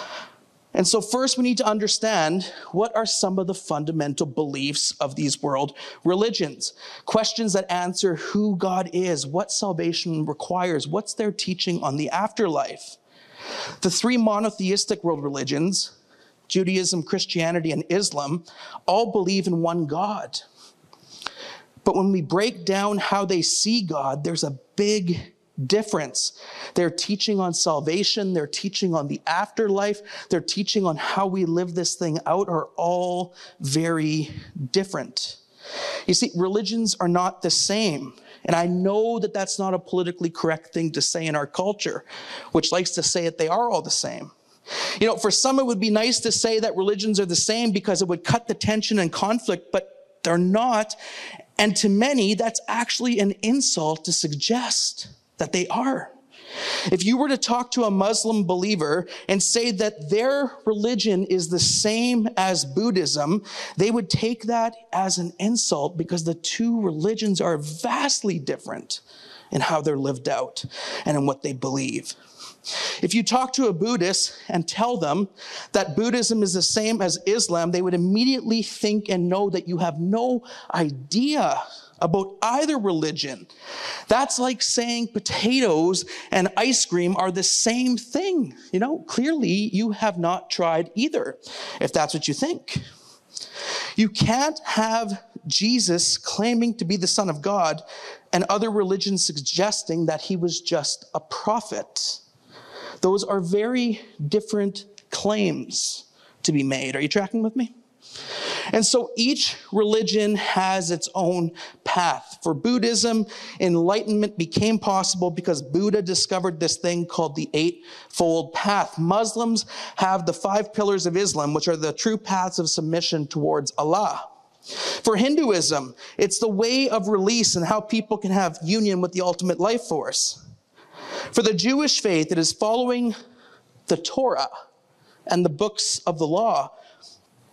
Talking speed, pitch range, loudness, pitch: 155 wpm, 175-220 Hz, -23 LUFS, 195 Hz